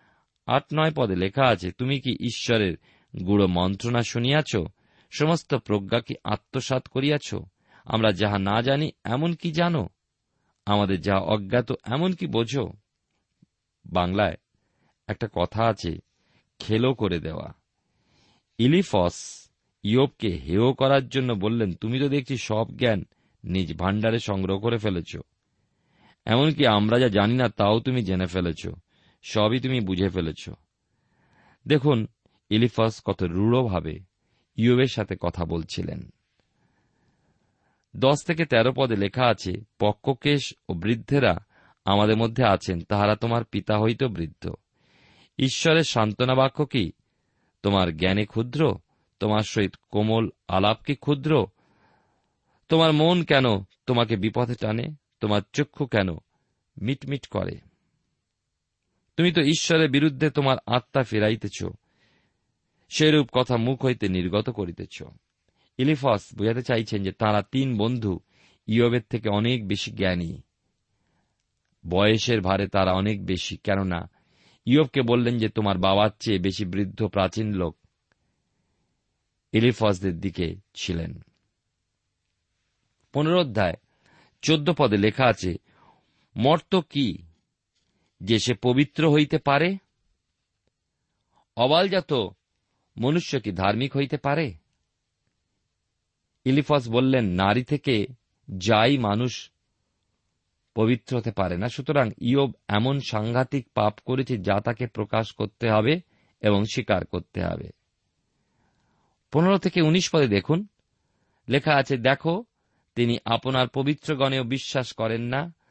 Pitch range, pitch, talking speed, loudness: 100-135 Hz, 115 Hz, 105 wpm, -24 LUFS